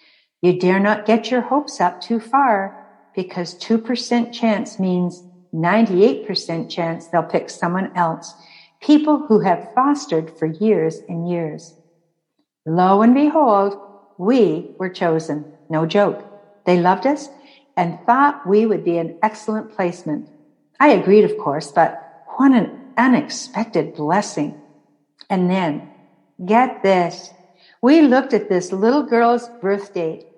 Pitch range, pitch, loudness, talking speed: 175-235 Hz, 195 Hz, -18 LUFS, 130 wpm